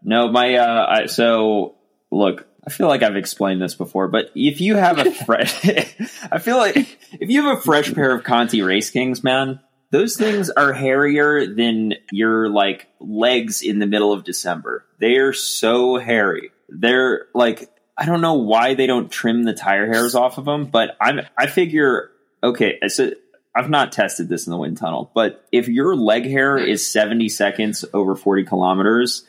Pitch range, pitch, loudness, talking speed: 105-140 Hz, 120 Hz, -18 LUFS, 185 wpm